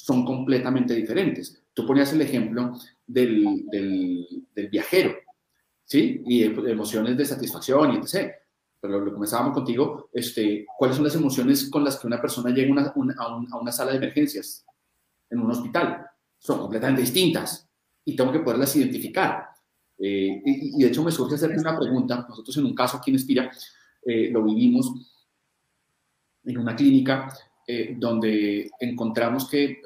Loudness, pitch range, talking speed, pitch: -24 LUFS, 120-150 Hz, 165 wpm, 130 Hz